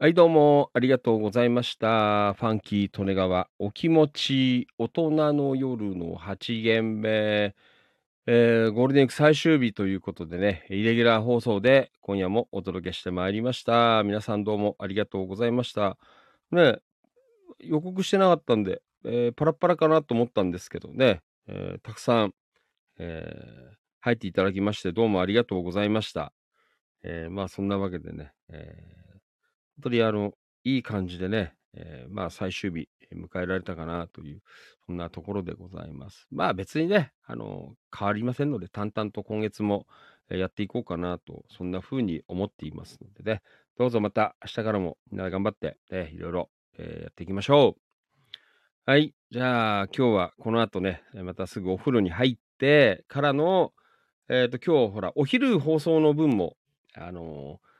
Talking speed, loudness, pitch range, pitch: 345 characters per minute, -25 LUFS, 95-125 Hz, 110 Hz